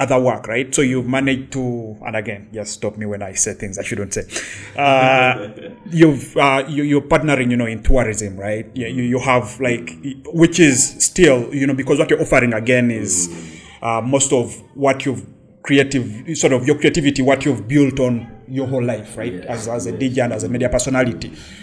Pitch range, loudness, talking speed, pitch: 110-135 Hz, -17 LUFS, 190 wpm, 125 Hz